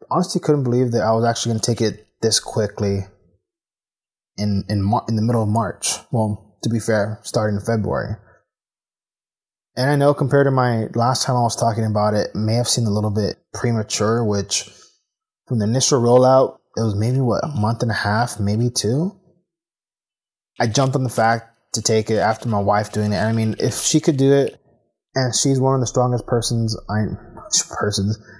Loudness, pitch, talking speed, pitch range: -19 LUFS, 115 Hz, 200 wpm, 105-125 Hz